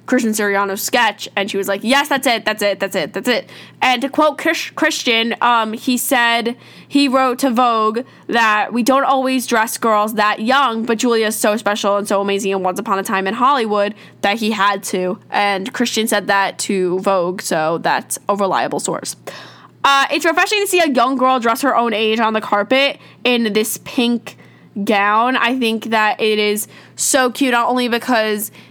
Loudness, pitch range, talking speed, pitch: -16 LUFS, 205-255 Hz, 200 wpm, 225 Hz